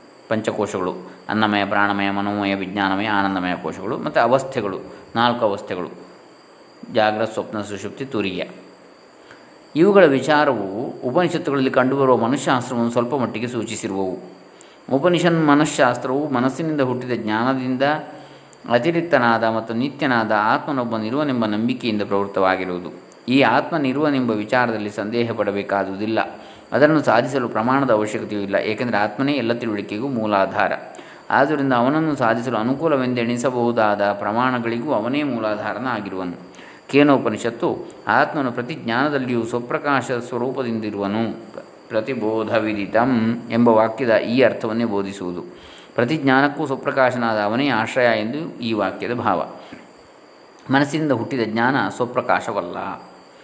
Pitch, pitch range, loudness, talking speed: 115 Hz, 105-130 Hz, -20 LUFS, 90 wpm